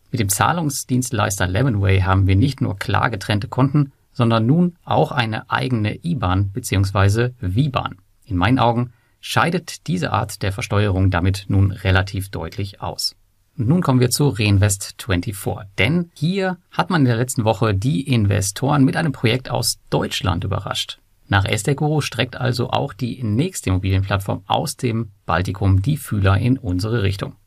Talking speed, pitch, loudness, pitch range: 155 wpm, 115 Hz, -20 LUFS, 100-130 Hz